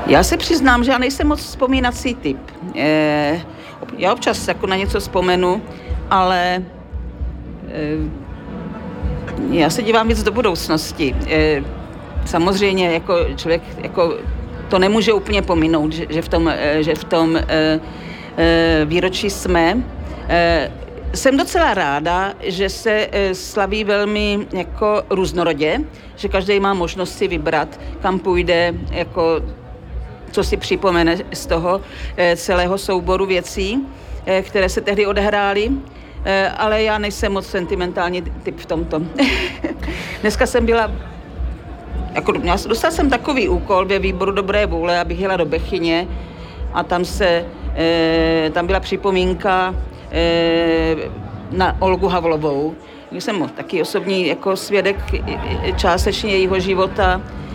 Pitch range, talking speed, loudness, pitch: 165-205 Hz, 120 wpm, -18 LUFS, 185 Hz